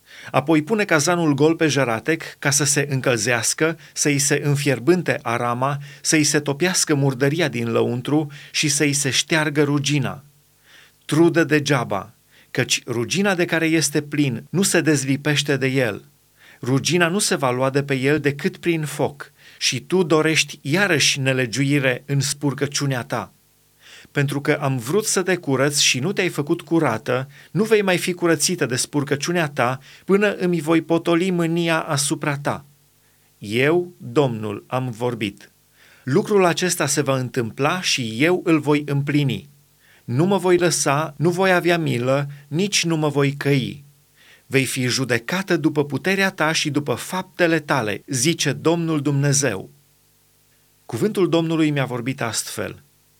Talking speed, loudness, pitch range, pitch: 145 wpm, -20 LUFS, 135-165 Hz, 145 Hz